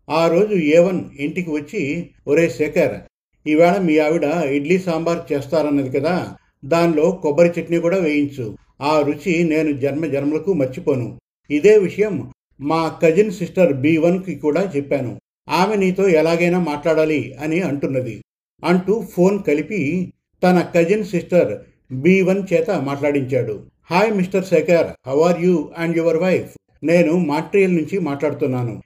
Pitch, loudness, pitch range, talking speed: 165 Hz, -18 LUFS, 150-180 Hz, 135 wpm